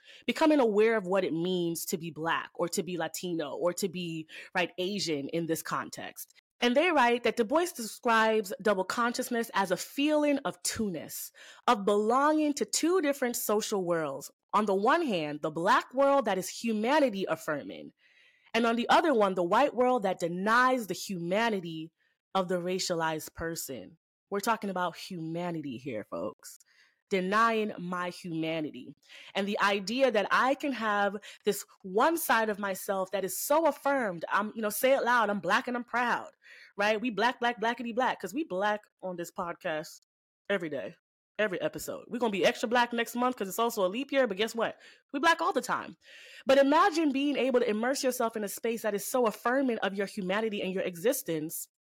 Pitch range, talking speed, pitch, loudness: 185-250 Hz, 190 wpm, 215 Hz, -29 LUFS